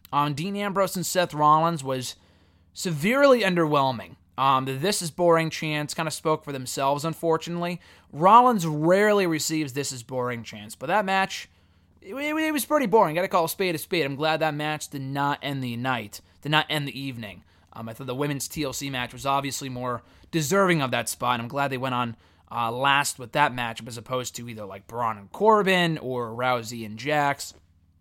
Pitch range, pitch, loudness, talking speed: 125-165 Hz, 140 Hz, -24 LUFS, 205 wpm